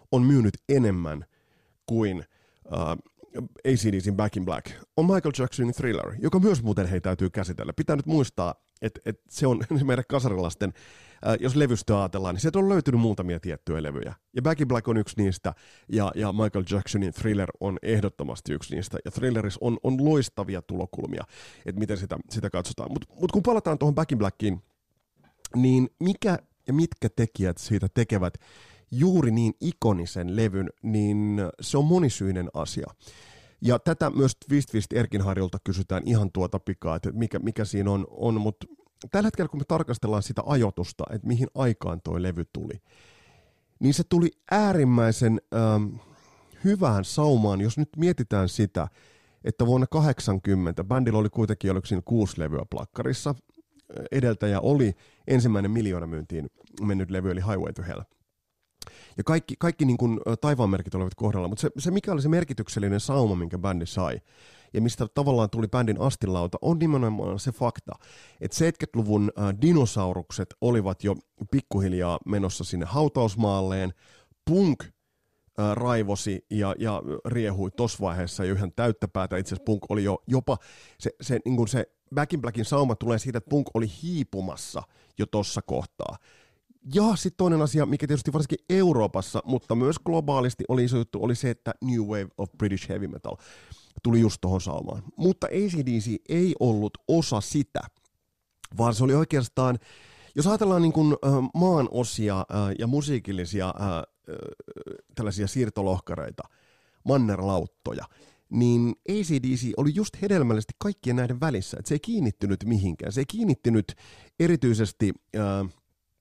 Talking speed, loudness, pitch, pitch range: 150 wpm, -26 LUFS, 110 Hz, 100-135 Hz